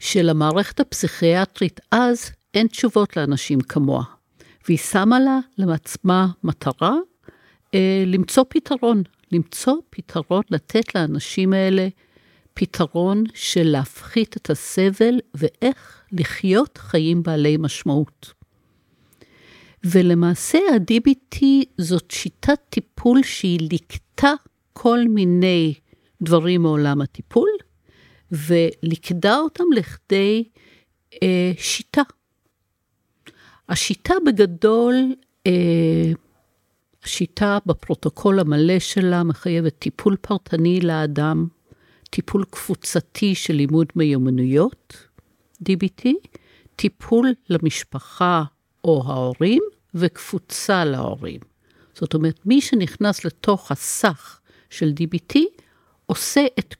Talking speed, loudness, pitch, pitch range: 85 wpm, -20 LUFS, 185 Hz, 165-225 Hz